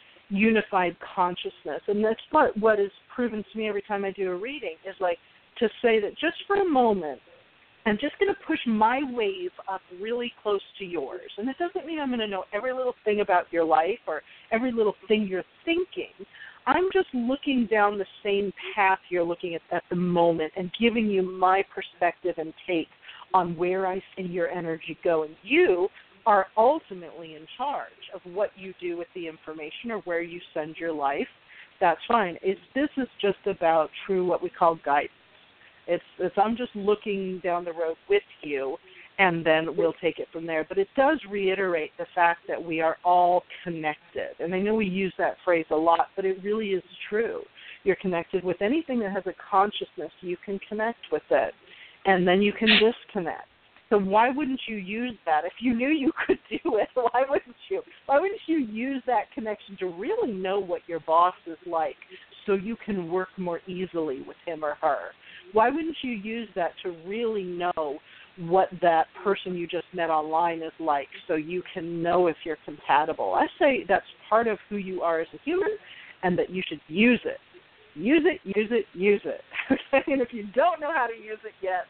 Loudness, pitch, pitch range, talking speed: -26 LUFS, 195 Hz, 175-230 Hz, 200 wpm